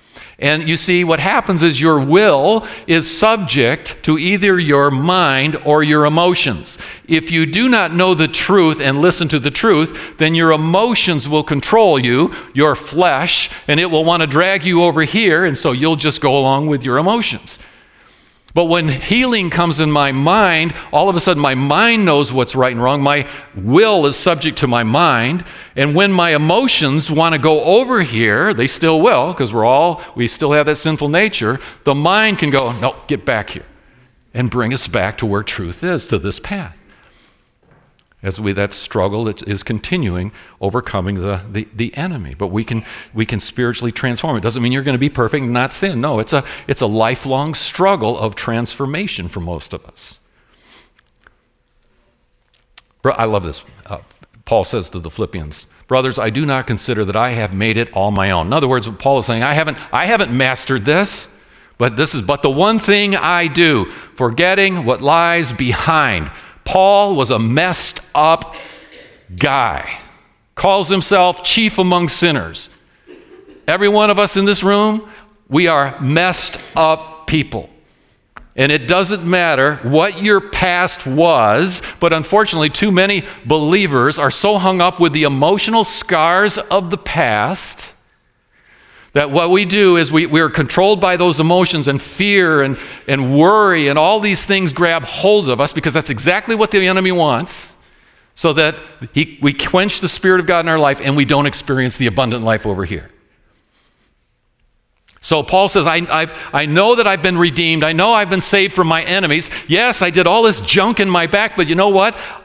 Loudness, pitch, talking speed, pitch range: -14 LUFS, 155 Hz, 185 wpm, 130-185 Hz